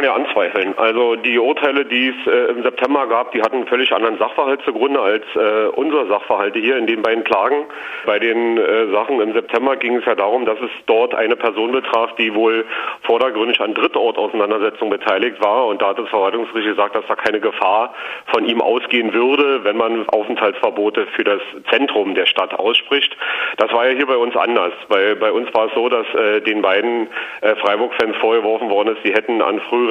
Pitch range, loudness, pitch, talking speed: 115-140 Hz, -16 LUFS, 120 Hz, 200 wpm